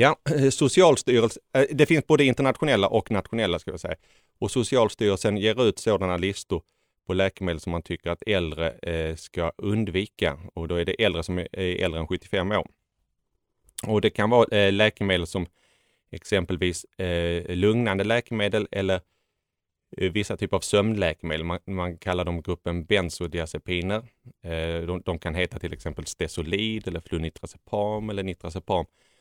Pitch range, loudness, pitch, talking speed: 85-105 Hz, -25 LUFS, 95 Hz, 135 wpm